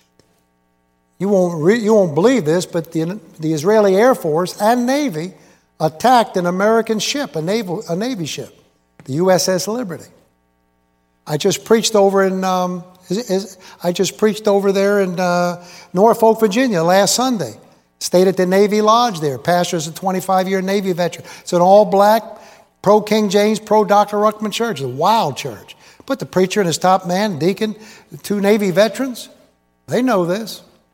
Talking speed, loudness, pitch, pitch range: 170 wpm, -16 LUFS, 190 Hz, 170-215 Hz